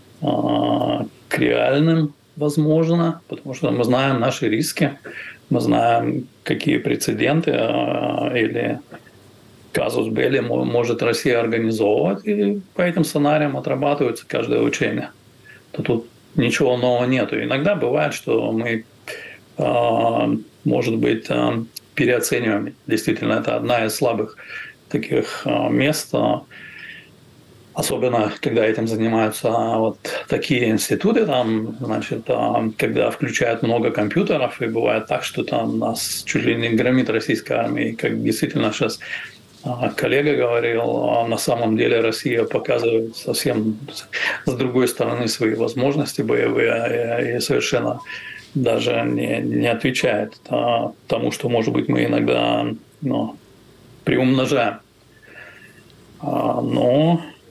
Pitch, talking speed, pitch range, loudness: 120 Hz, 110 wpm, 110-145 Hz, -20 LUFS